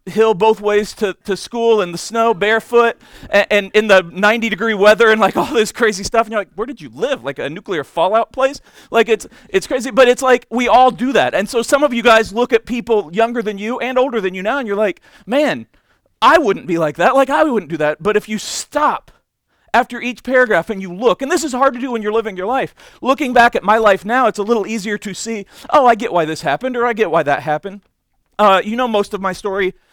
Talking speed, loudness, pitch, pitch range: 260 wpm, -15 LUFS, 225 Hz, 205-245 Hz